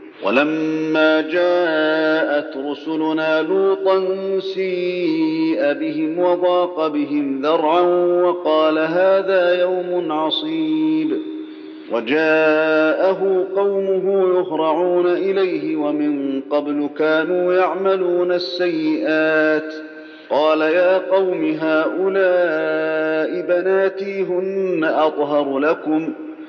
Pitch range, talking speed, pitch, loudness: 155-190 Hz, 70 wpm, 175 Hz, -18 LUFS